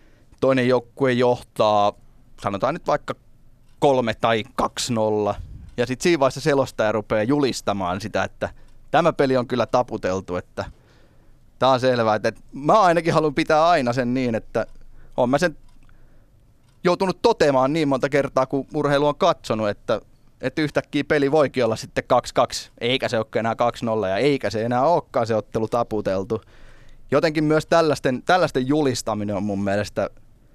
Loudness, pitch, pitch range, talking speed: -21 LUFS, 125 Hz, 110-140 Hz, 155 wpm